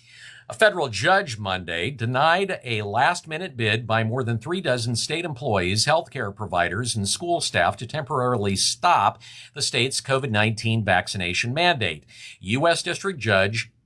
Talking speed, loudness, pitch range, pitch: 145 wpm, -22 LUFS, 105-150 Hz, 120 Hz